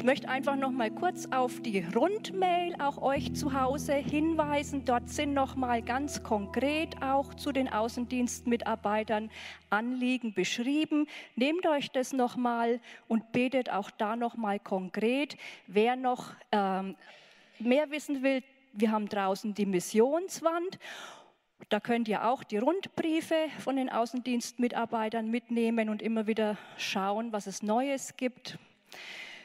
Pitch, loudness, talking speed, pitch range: 245 Hz, -31 LUFS, 135 wpm, 220-275 Hz